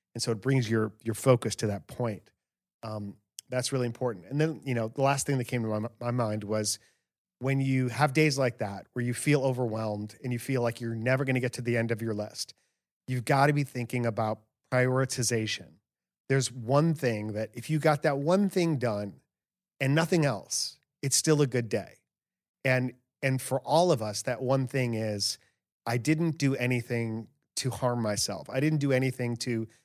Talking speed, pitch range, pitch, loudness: 205 wpm, 110-135 Hz, 125 Hz, -29 LUFS